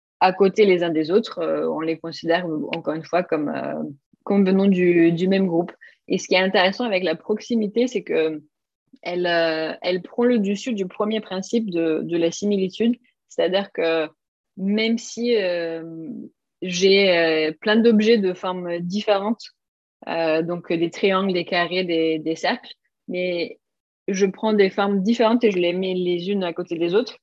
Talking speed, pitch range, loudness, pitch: 175 wpm, 170-210 Hz, -21 LUFS, 185 Hz